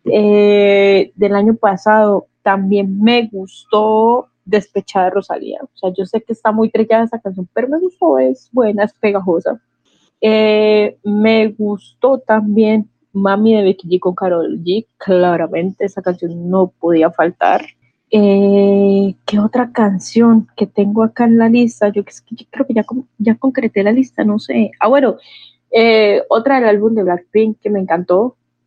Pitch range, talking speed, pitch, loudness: 195-225 Hz, 155 wpm, 210 Hz, -14 LUFS